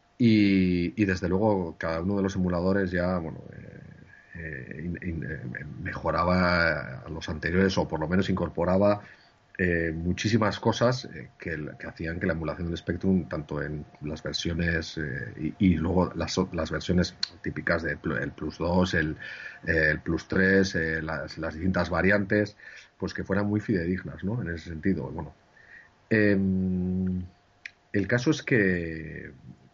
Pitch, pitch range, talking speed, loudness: 90 Hz, 80-95 Hz, 155 wpm, -27 LUFS